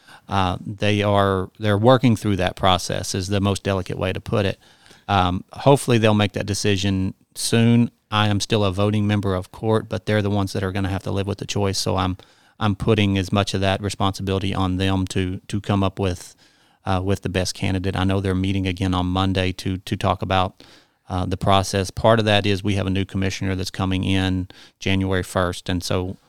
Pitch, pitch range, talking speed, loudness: 95 Hz, 95-105 Hz, 220 wpm, -21 LUFS